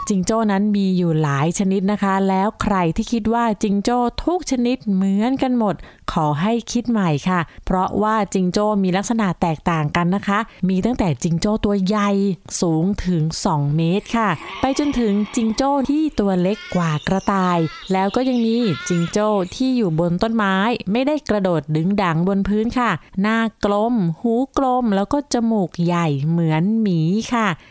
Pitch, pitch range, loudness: 205 Hz, 180-225 Hz, -19 LUFS